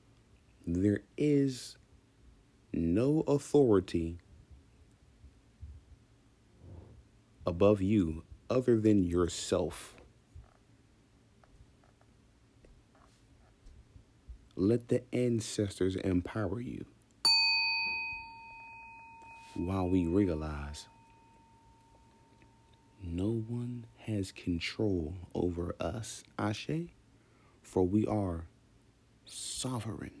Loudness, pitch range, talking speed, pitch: -32 LUFS, 95-130 Hz, 55 wpm, 110 Hz